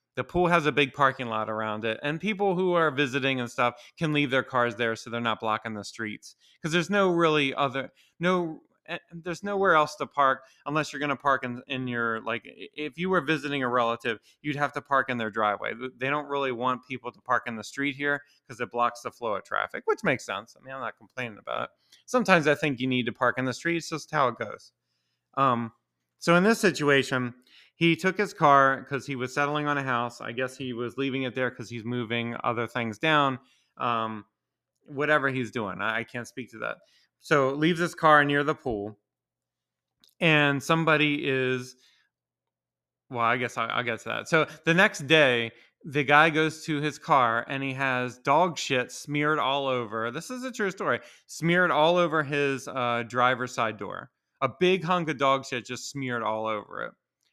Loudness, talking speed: -26 LUFS, 210 wpm